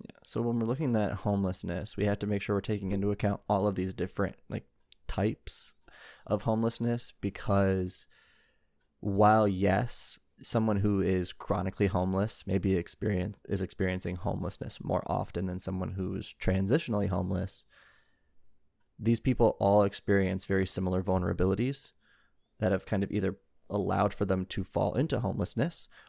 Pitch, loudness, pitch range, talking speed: 100 Hz, -31 LUFS, 95-105 Hz, 145 wpm